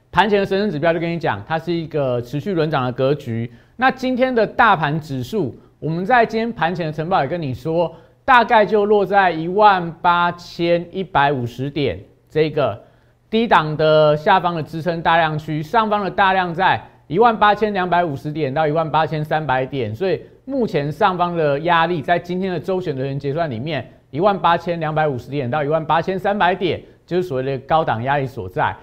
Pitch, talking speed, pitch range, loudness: 165 Hz, 300 characters per minute, 150-190 Hz, -18 LUFS